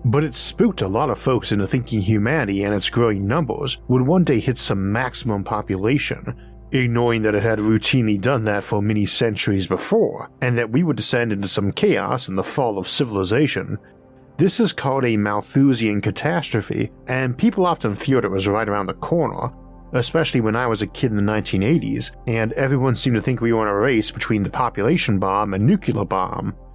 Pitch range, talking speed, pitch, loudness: 105-130 Hz, 195 wpm, 115 Hz, -20 LUFS